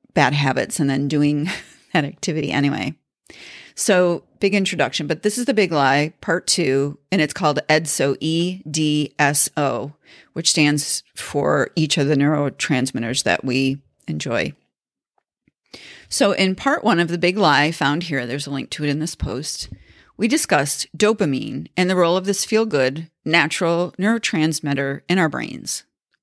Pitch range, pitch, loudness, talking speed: 145-180 Hz, 155 Hz, -19 LUFS, 160 wpm